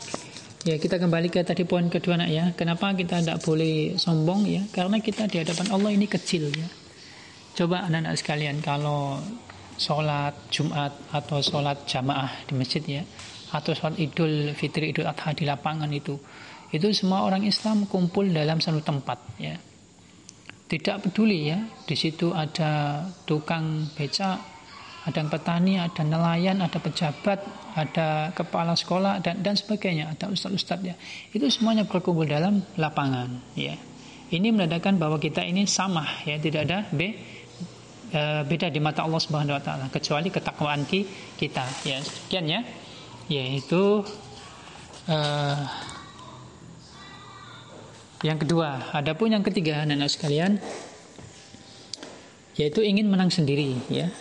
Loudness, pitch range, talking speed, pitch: -26 LUFS, 150-185 Hz, 135 wpm, 160 Hz